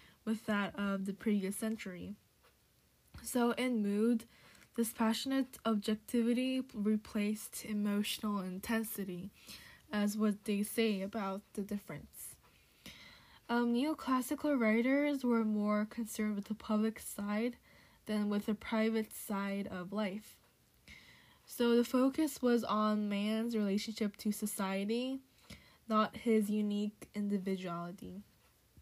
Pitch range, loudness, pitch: 205-235 Hz, -36 LUFS, 215 Hz